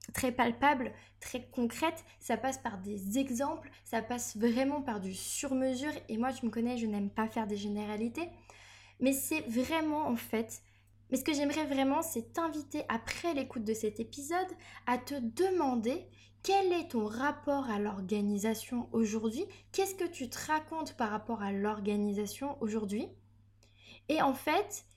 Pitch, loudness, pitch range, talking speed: 245 Hz, -34 LUFS, 215-290 Hz, 160 wpm